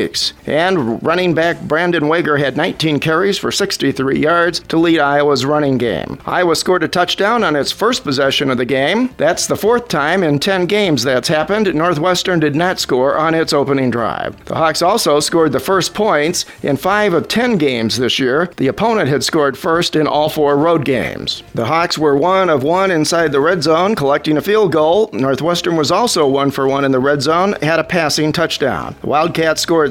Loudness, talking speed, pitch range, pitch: -14 LUFS, 200 wpm, 145-175 Hz, 160 Hz